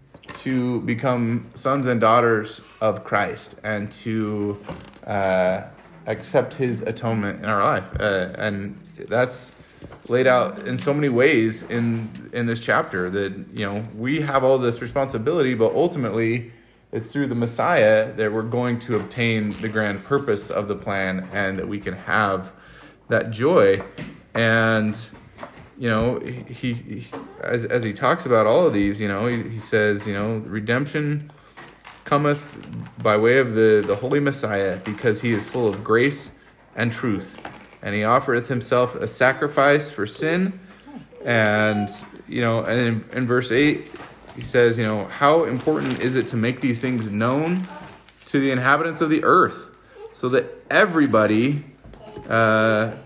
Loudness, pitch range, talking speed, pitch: -21 LUFS, 110-130 Hz, 160 wpm, 115 Hz